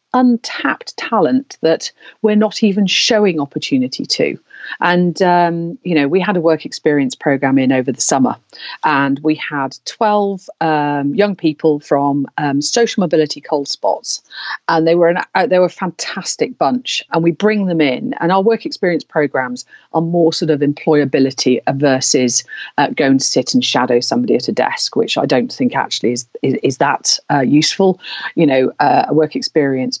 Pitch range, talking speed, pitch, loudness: 145-195 Hz, 180 wpm, 160 Hz, -15 LUFS